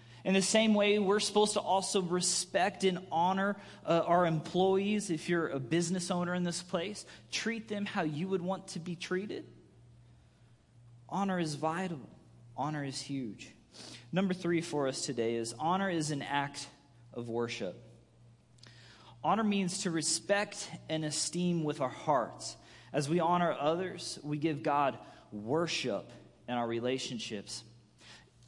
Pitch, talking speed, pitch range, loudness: 160 Hz, 145 wpm, 125-185 Hz, -33 LUFS